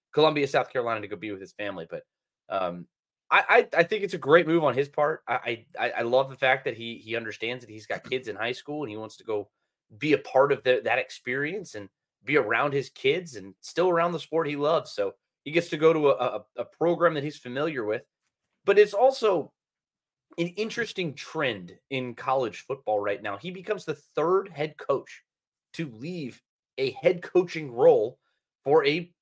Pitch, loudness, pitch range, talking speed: 150 Hz, -26 LUFS, 125-180 Hz, 210 wpm